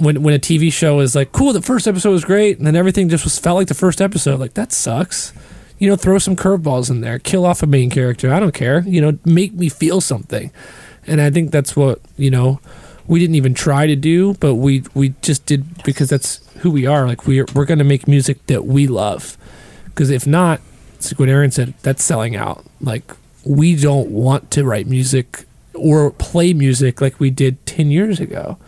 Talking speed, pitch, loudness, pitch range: 225 wpm, 145 Hz, -15 LUFS, 135-170 Hz